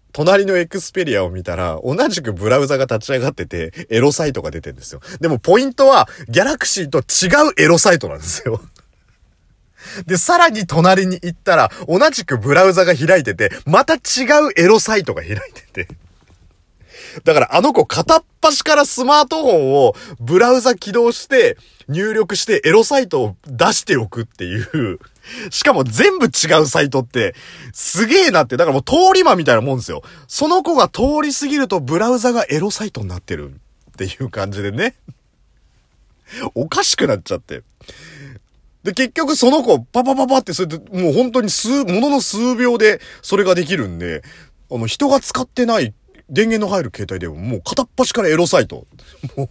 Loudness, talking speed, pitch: -14 LUFS, 355 characters per minute, 195 Hz